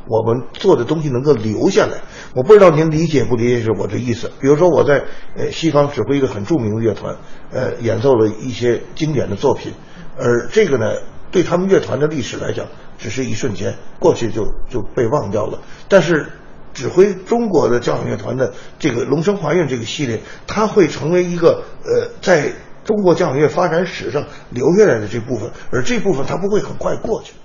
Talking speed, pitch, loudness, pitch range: 300 characters per minute, 150 Hz, -16 LUFS, 120-180 Hz